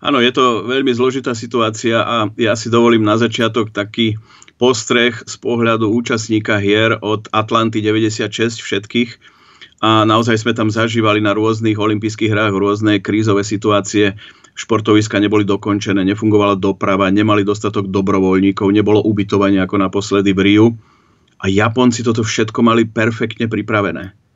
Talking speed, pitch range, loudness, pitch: 135 wpm, 105-115 Hz, -14 LUFS, 110 Hz